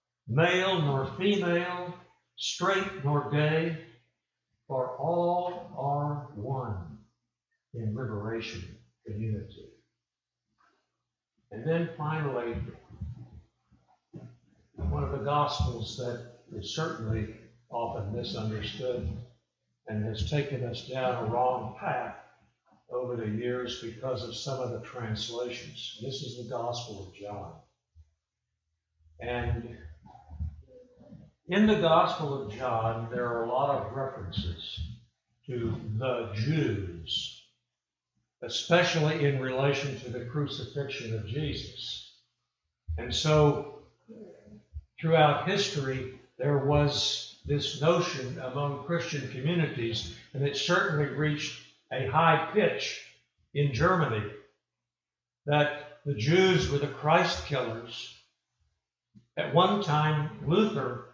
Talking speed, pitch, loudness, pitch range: 100 wpm, 130 Hz, -30 LUFS, 110-150 Hz